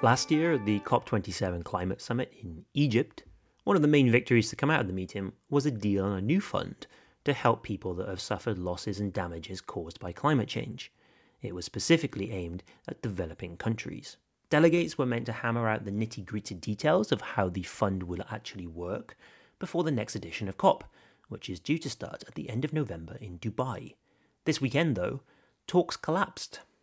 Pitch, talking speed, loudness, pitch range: 110 Hz, 195 wpm, -30 LUFS, 95-135 Hz